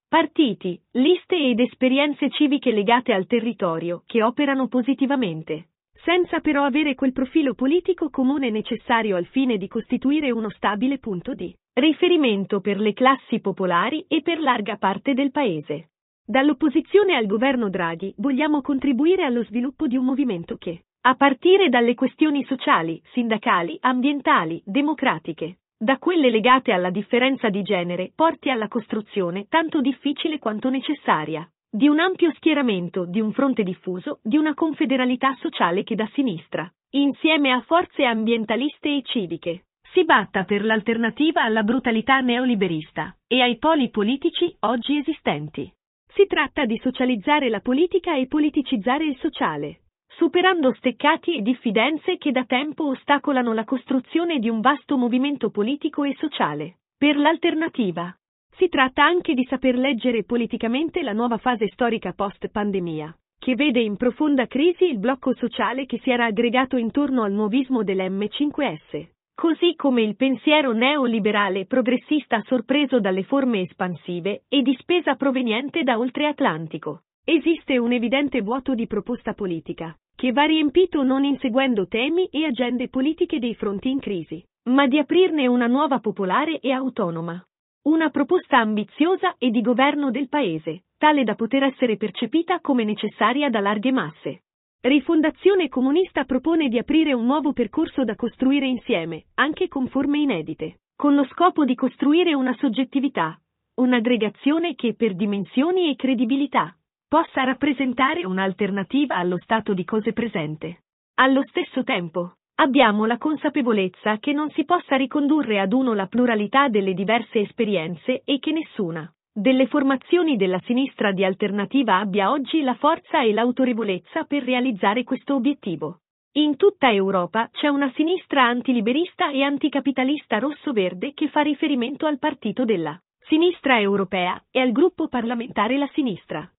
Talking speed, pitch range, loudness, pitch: 140 wpm, 220-290 Hz, -21 LUFS, 255 Hz